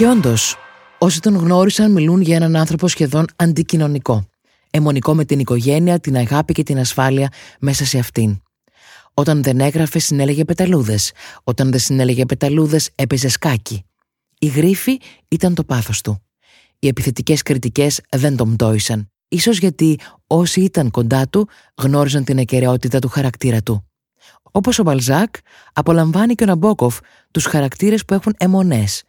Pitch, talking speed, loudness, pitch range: 145 Hz, 145 wpm, -16 LUFS, 130-170 Hz